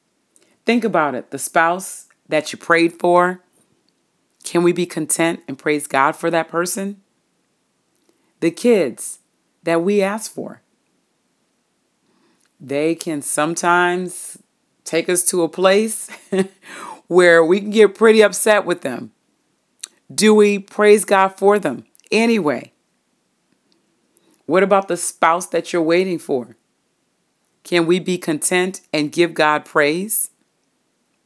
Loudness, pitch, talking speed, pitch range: -17 LUFS, 175 Hz, 125 wpm, 165-195 Hz